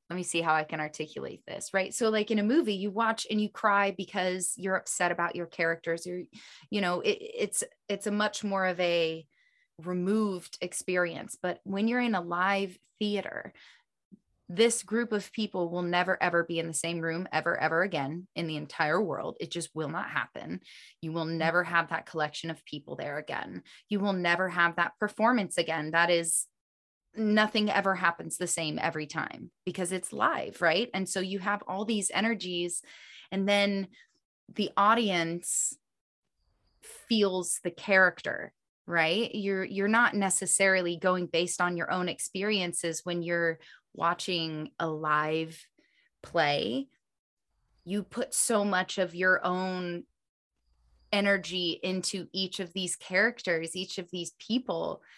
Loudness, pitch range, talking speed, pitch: -29 LUFS, 170-205 Hz, 160 wpm, 185 Hz